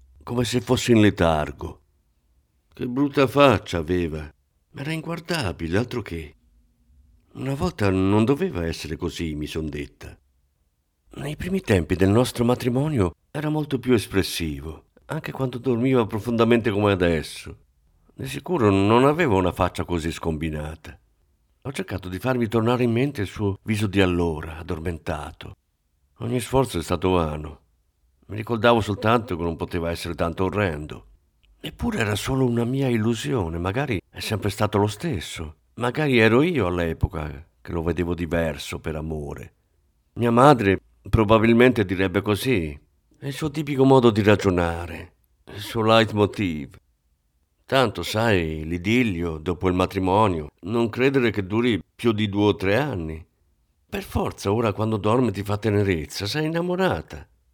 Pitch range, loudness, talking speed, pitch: 80-120 Hz, -23 LUFS, 145 wpm, 95 Hz